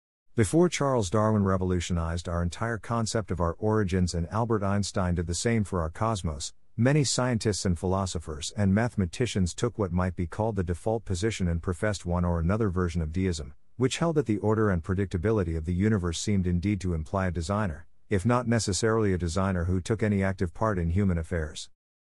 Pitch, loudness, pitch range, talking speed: 95 Hz, -28 LUFS, 90-110 Hz, 190 wpm